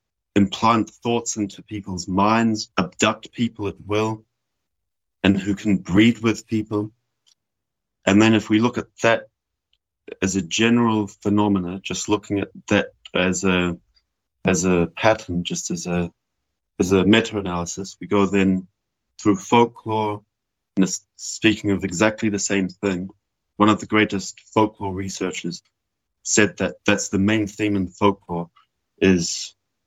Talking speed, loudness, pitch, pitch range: 140 wpm, -21 LUFS, 100 Hz, 95-110 Hz